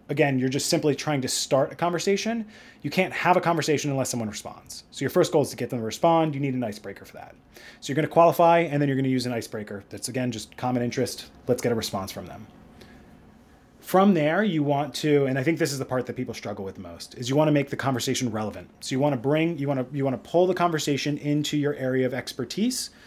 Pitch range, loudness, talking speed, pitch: 125-155 Hz, -25 LUFS, 265 wpm, 140 Hz